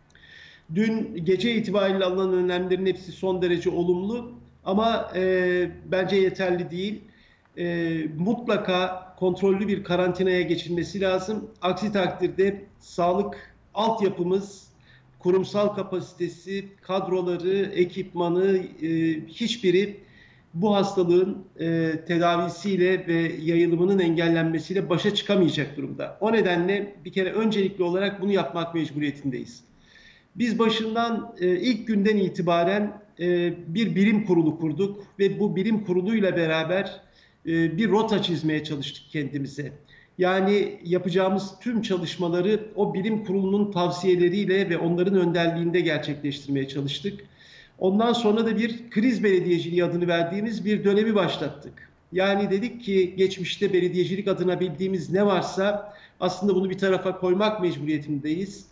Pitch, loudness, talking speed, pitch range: 185 Hz, -24 LUFS, 110 wpm, 175-200 Hz